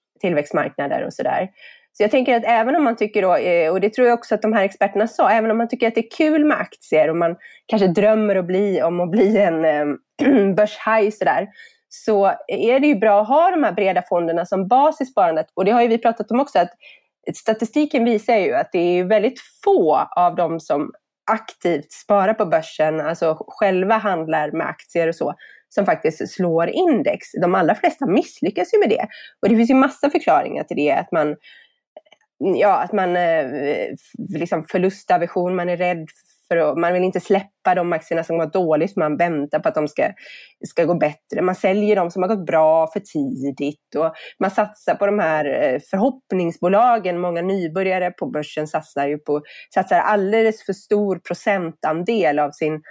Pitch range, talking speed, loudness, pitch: 170-225 Hz, 195 wpm, -19 LUFS, 195 Hz